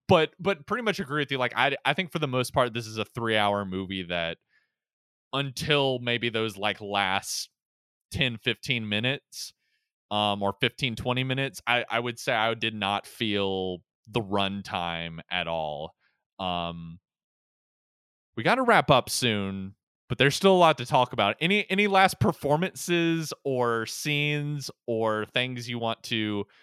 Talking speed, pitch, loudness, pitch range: 165 wpm, 120 Hz, -26 LUFS, 100-140 Hz